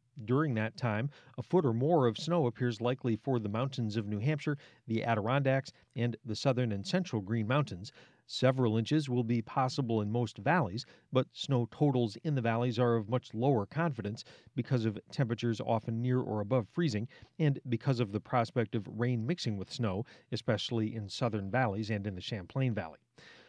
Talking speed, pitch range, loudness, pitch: 185 wpm, 110-135 Hz, -33 LUFS, 120 Hz